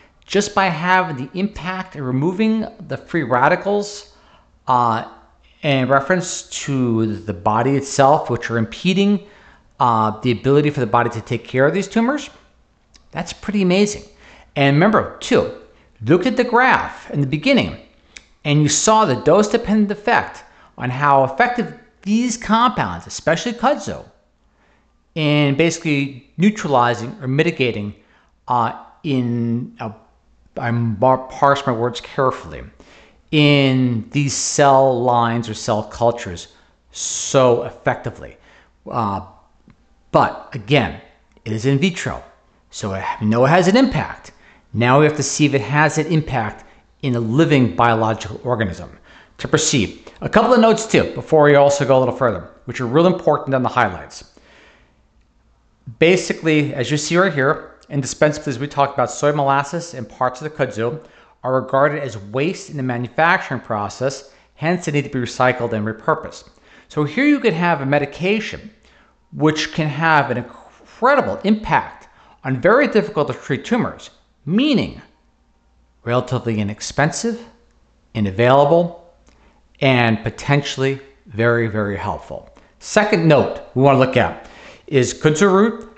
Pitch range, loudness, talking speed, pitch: 120-170 Hz, -18 LUFS, 145 wpm, 140 Hz